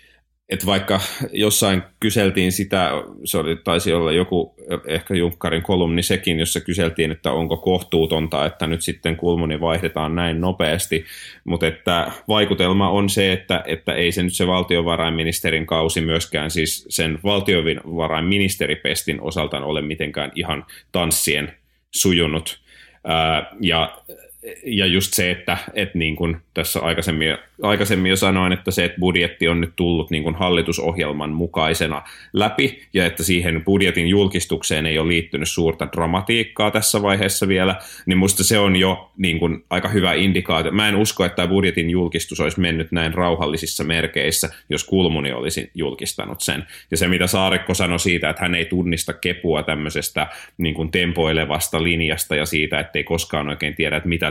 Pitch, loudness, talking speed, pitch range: 85 Hz, -19 LUFS, 150 wpm, 80-95 Hz